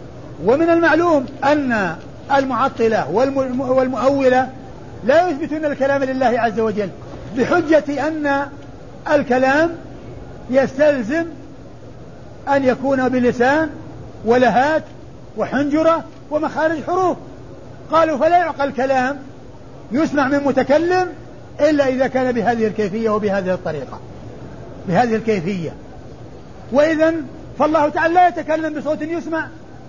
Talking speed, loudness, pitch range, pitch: 90 wpm, -17 LUFS, 245-310 Hz, 275 Hz